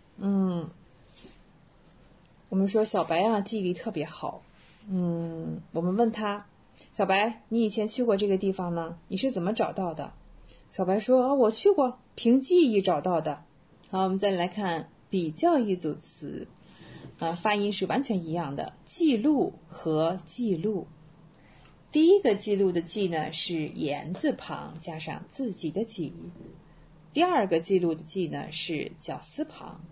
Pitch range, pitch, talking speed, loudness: 165-220 Hz, 190 Hz, 215 characters per minute, -28 LUFS